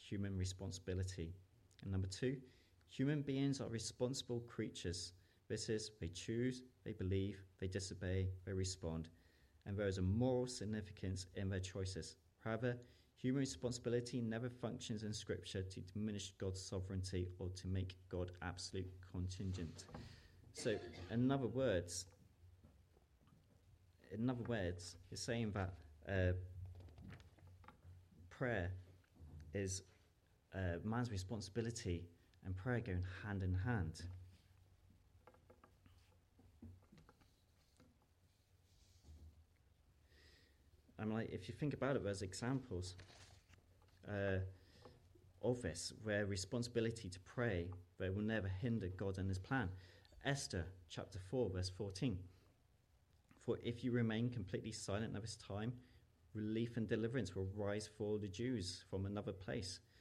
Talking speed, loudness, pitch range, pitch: 115 wpm, -45 LUFS, 90-115 Hz, 95 Hz